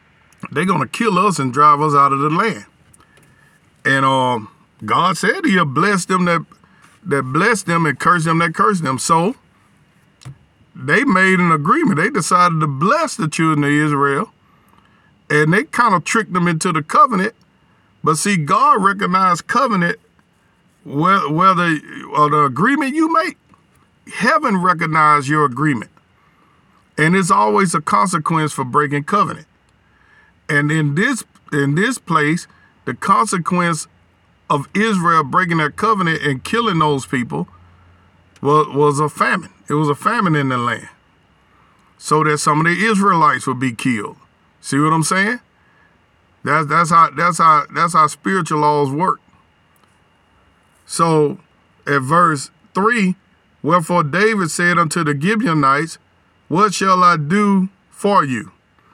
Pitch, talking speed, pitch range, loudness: 165 Hz, 145 wpm, 145-190 Hz, -15 LUFS